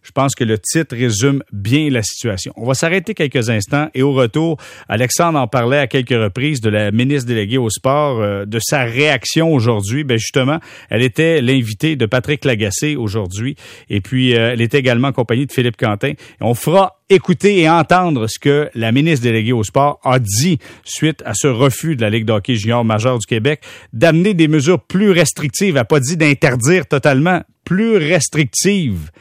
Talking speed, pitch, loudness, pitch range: 195 wpm, 135 Hz, -15 LUFS, 115-155 Hz